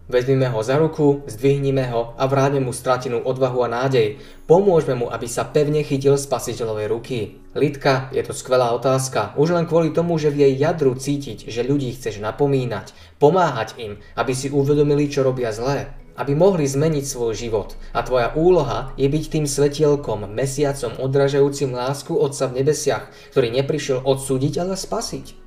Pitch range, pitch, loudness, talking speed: 125-145 Hz, 140 Hz, -20 LUFS, 165 wpm